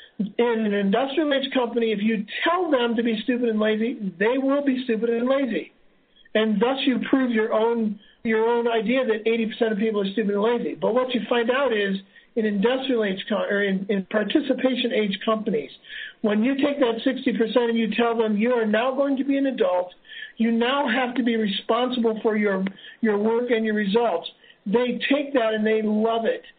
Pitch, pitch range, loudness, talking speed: 230 Hz, 215-255 Hz, -23 LUFS, 200 wpm